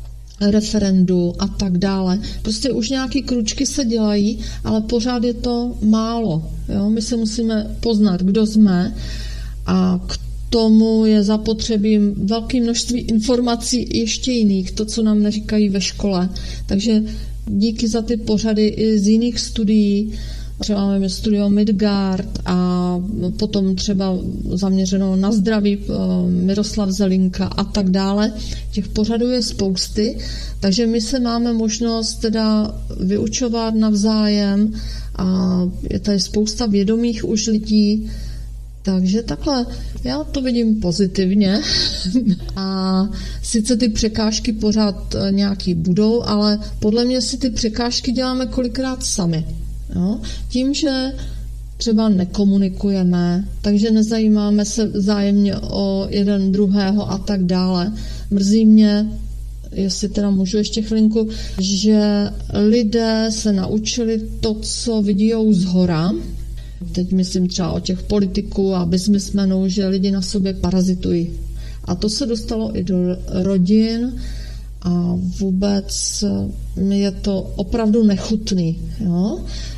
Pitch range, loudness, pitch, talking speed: 190-220 Hz, -18 LUFS, 205 Hz, 120 wpm